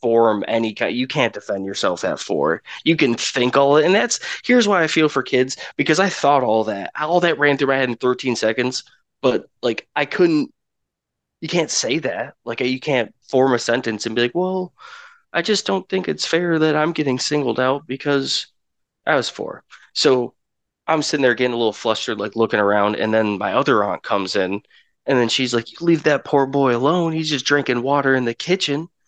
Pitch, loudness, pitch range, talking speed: 135 Hz, -19 LUFS, 120-165 Hz, 215 wpm